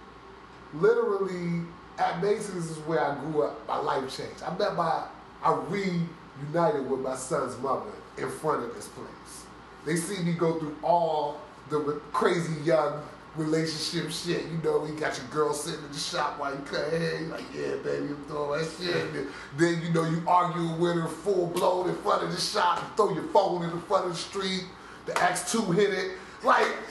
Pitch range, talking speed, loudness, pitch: 150-180 Hz, 195 wpm, -28 LUFS, 165 Hz